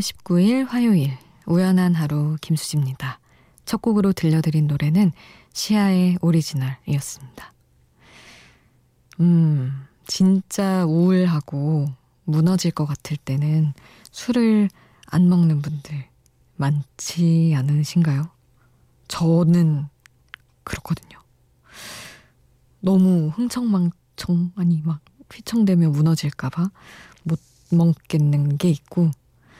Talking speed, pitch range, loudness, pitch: 200 characters per minute, 140-180 Hz, -20 LUFS, 160 Hz